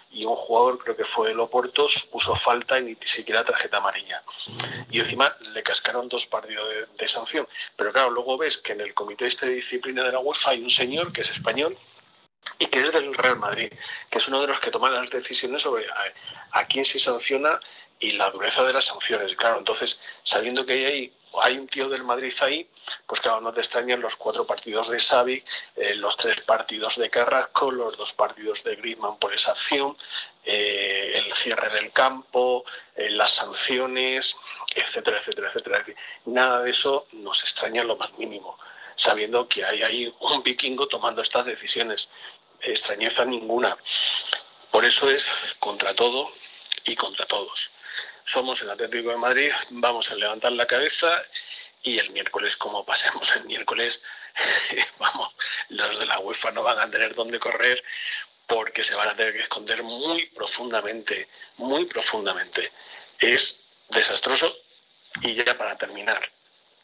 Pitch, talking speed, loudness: 360 Hz, 170 wpm, -24 LUFS